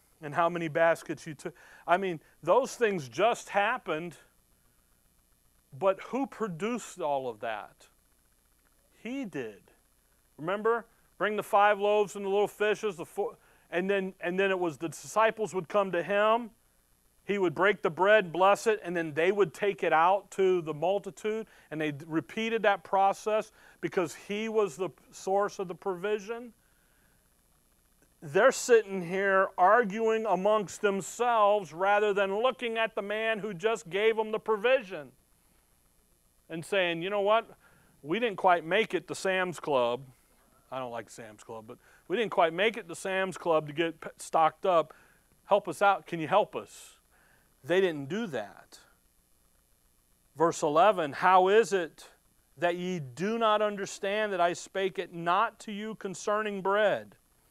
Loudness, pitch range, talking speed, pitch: -29 LUFS, 170-210 Hz, 160 wpm, 195 Hz